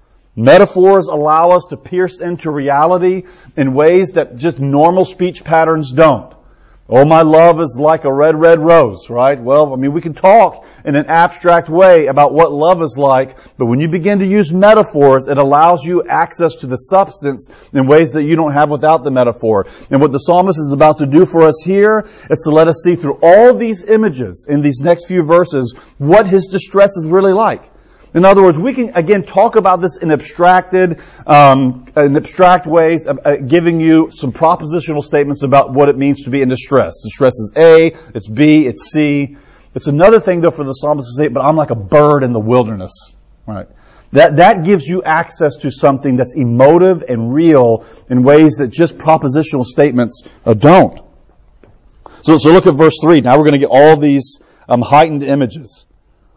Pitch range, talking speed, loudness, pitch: 140-175 Hz, 195 wpm, -10 LUFS, 155 Hz